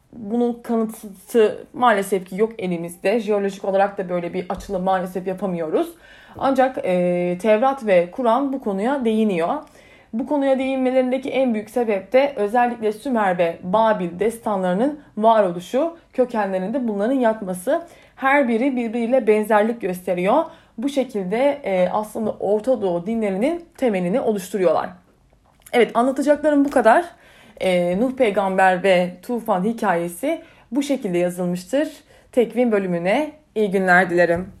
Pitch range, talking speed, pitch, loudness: 190-260 Hz, 120 wpm, 220 Hz, -20 LUFS